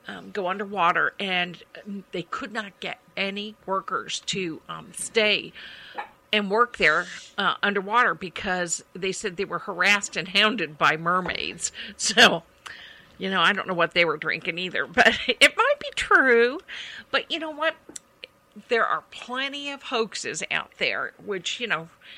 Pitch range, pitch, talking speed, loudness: 185-245 Hz, 205 Hz, 155 wpm, -23 LUFS